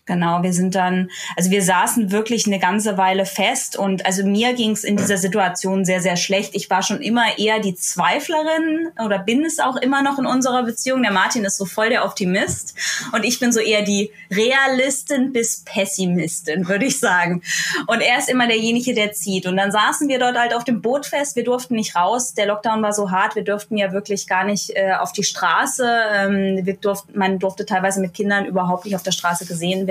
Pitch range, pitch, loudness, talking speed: 190-235 Hz, 205 Hz, -19 LUFS, 220 wpm